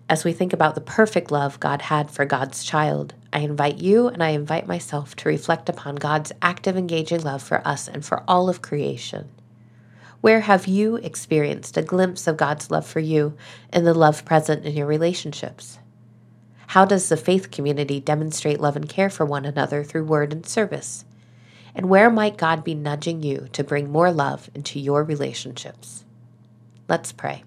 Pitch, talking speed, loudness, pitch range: 150 Hz, 180 wpm, -21 LUFS, 135-170 Hz